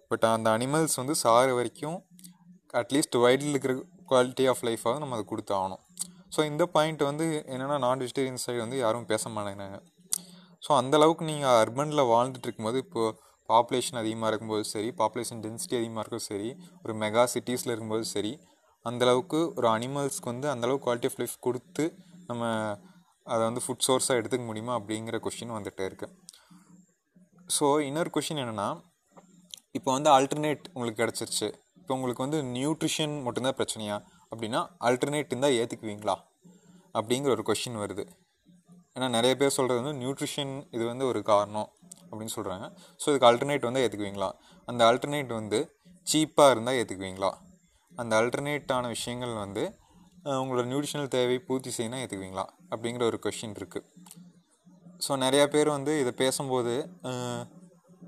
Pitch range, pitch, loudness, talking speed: 115-155 Hz, 130 Hz, -29 LUFS, 140 wpm